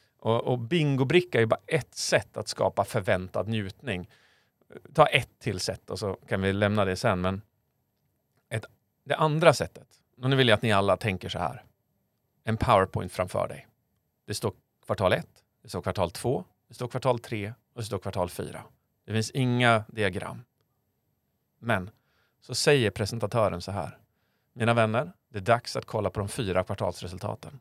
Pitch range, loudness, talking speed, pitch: 100-125 Hz, -27 LUFS, 170 wpm, 110 Hz